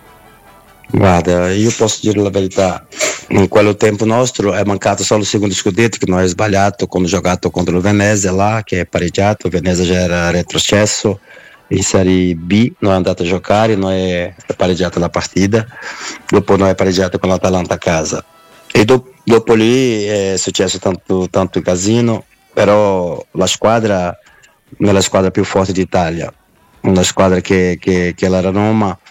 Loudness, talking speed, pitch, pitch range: -13 LUFS, 175 wpm, 95 Hz, 90-105 Hz